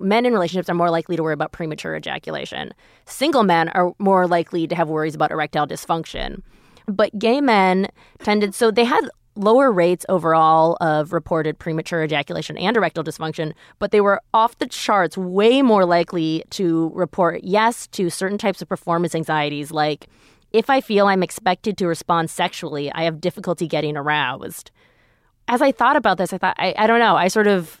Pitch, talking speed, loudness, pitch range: 175 Hz, 185 wpm, -19 LUFS, 160-205 Hz